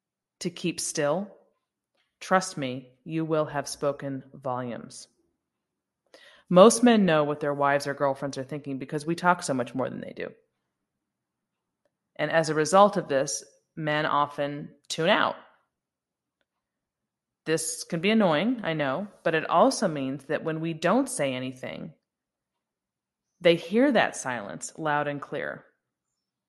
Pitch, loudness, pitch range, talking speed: 155 Hz, -26 LUFS, 140-180 Hz, 140 wpm